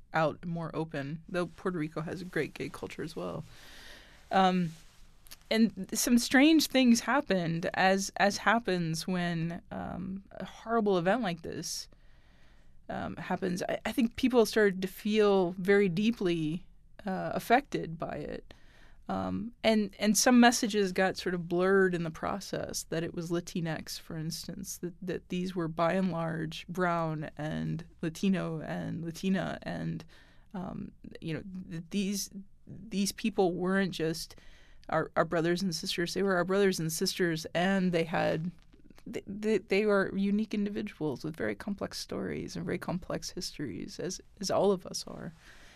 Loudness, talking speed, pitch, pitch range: -31 LUFS, 150 wpm, 185 Hz, 165-205 Hz